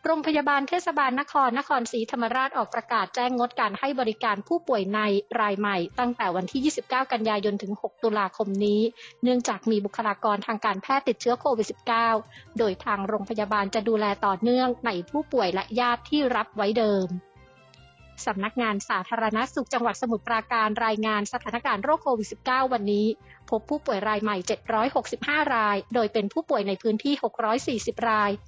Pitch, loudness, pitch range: 225 Hz, -26 LUFS, 210-250 Hz